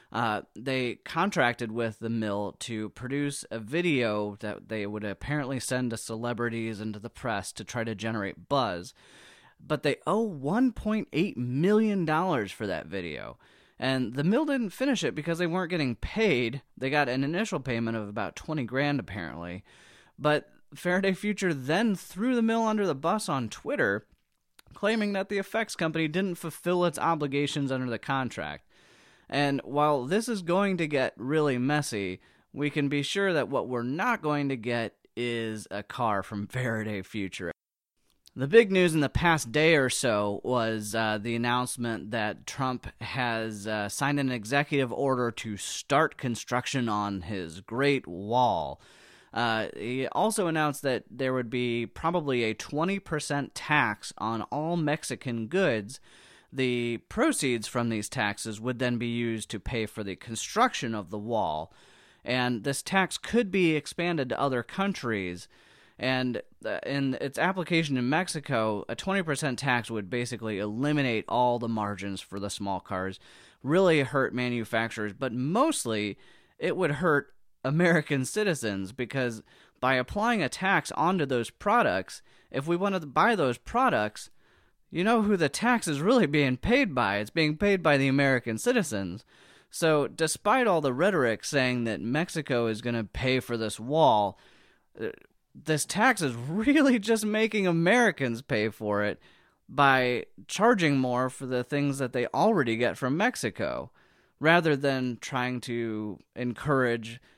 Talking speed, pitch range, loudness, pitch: 155 wpm, 115-160 Hz, -28 LUFS, 130 Hz